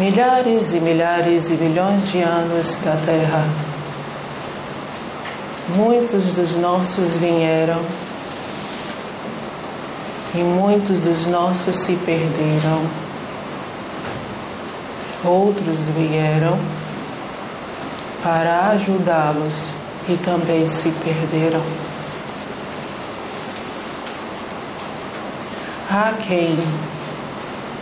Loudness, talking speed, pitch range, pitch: -20 LUFS, 65 wpm, 160-180 Hz, 170 Hz